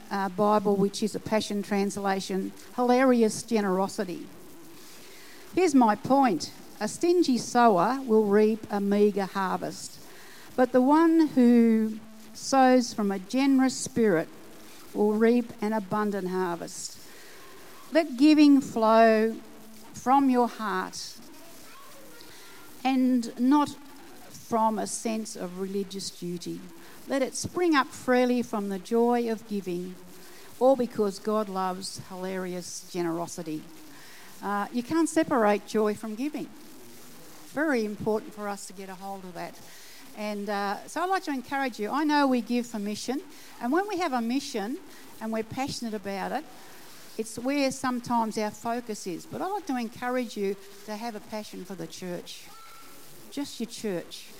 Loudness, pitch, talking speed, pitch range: -27 LUFS, 225 Hz, 140 wpm, 205-265 Hz